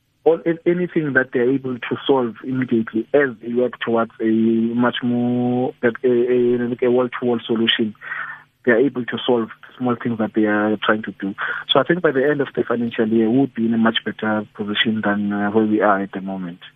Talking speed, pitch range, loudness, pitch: 210 wpm, 110-125 Hz, -19 LUFS, 120 Hz